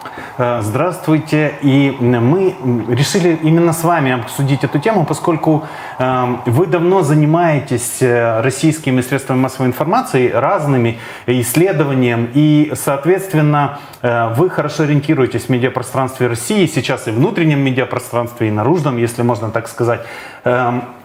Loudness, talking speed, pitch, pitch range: -15 LUFS, 110 wpm, 135 Hz, 125-155 Hz